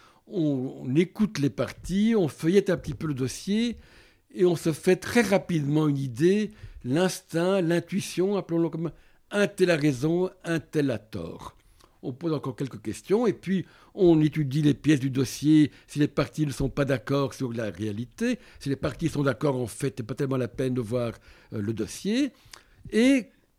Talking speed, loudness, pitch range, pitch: 180 wpm, -26 LUFS, 130-180 Hz, 150 Hz